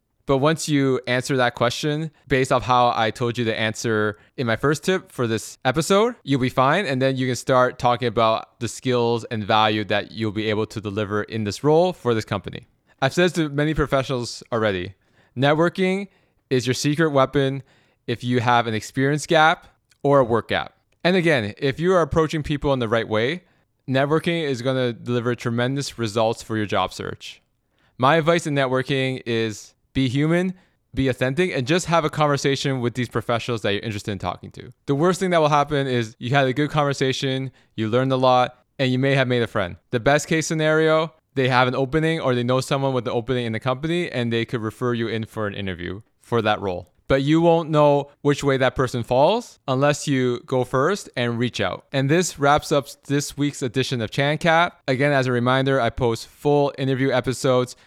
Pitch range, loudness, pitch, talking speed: 115-145 Hz, -21 LUFS, 130 Hz, 210 wpm